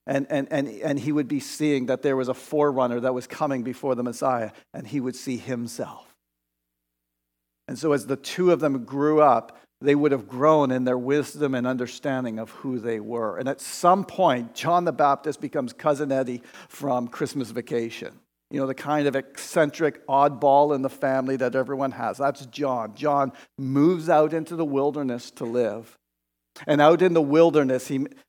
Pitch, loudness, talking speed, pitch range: 135 Hz, -24 LUFS, 185 wpm, 125-150 Hz